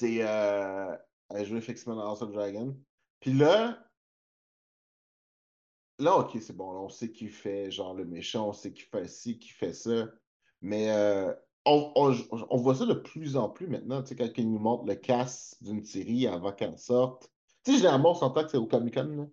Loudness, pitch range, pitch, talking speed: -30 LUFS, 105-130 Hz, 115 Hz, 195 wpm